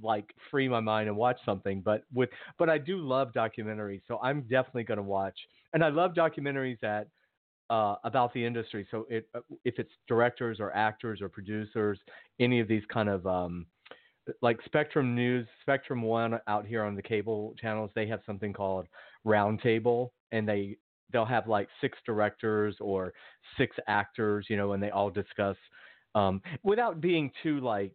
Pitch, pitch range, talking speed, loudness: 110 Hz, 105-125 Hz, 175 wpm, -31 LUFS